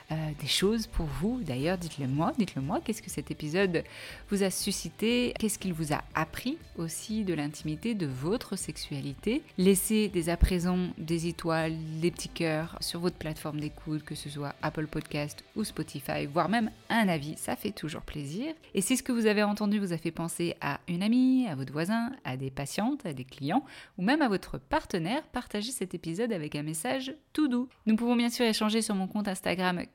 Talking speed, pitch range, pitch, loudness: 200 wpm, 155-220 Hz, 180 Hz, -31 LUFS